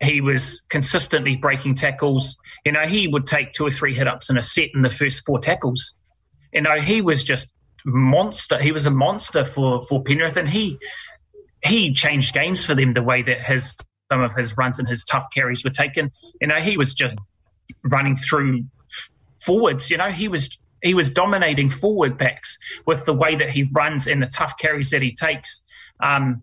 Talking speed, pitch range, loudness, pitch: 200 wpm, 130-155 Hz, -20 LUFS, 140 Hz